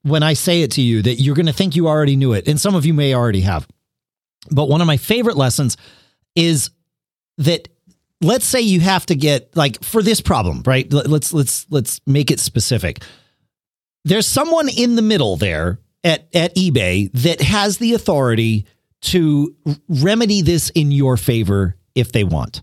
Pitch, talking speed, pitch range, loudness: 150 Hz, 185 wpm, 125-175 Hz, -16 LUFS